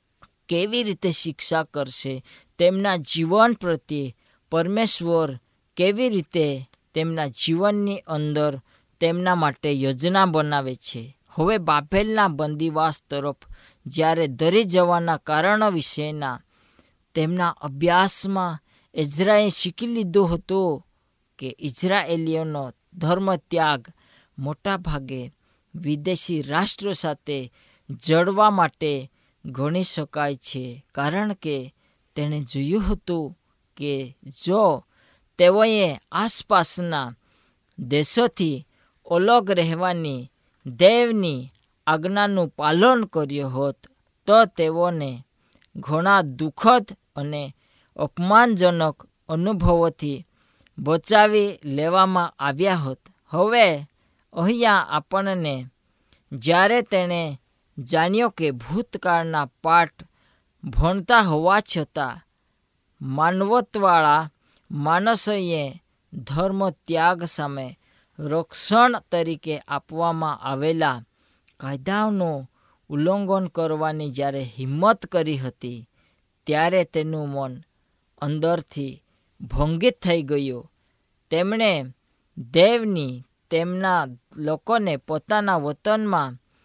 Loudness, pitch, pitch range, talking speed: -22 LUFS, 160 Hz, 140-185 Hz, 80 wpm